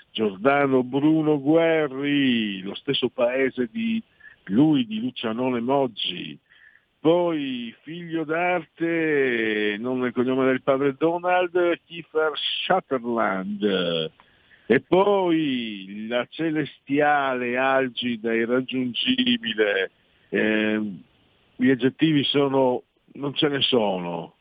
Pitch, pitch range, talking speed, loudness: 140 Hz, 125-165 Hz, 90 wpm, -23 LUFS